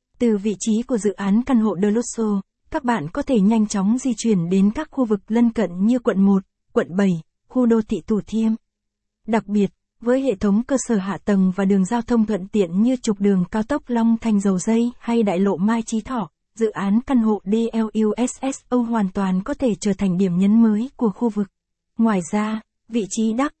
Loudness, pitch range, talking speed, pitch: -20 LUFS, 200-235 Hz, 220 wpm, 220 Hz